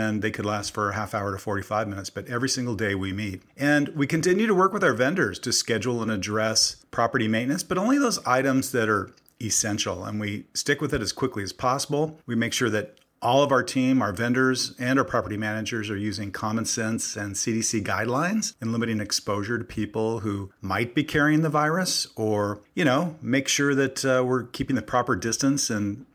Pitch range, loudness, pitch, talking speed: 105-135 Hz, -25 LUFS, 115 Hz, 210 wpm